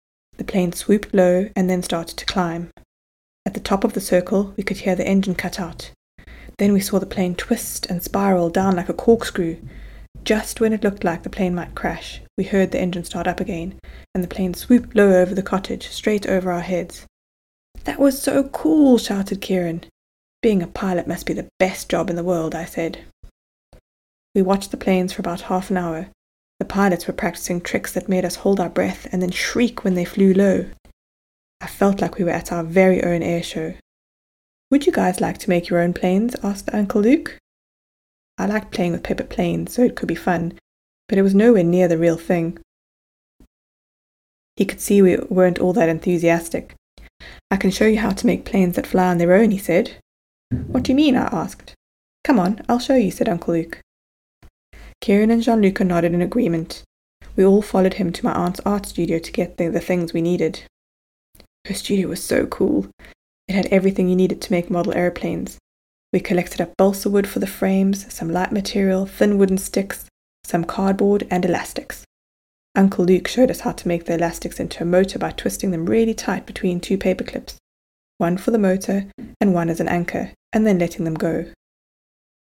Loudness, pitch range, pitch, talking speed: -20 LUFS, 170-200 Hz, 185 Hz, 200 wpm